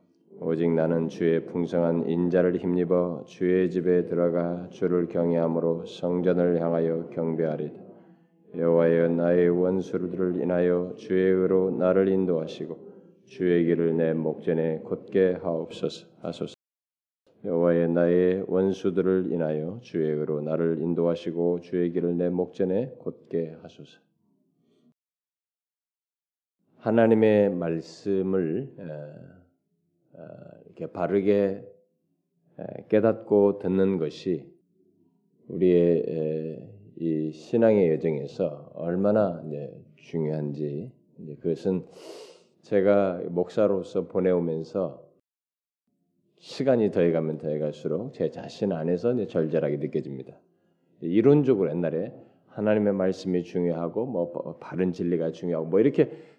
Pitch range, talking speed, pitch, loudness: 80-95 Hz, 245 characters per minute, 85 Hz, -25 LUFS